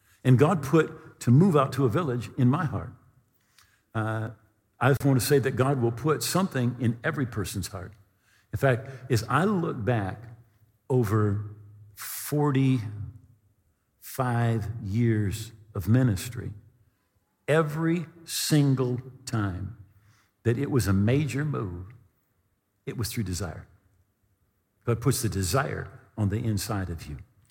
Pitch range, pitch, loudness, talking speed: 105-135 Hz, 115 Hz, -27 LUFS, 130 wpm